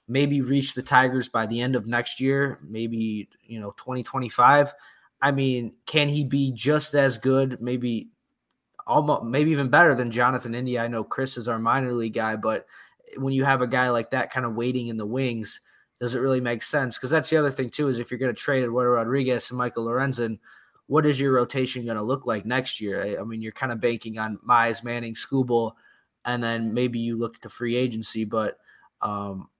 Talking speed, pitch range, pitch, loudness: 215 wpm, 115-135 Hz, 125 Hz, -24 LUFS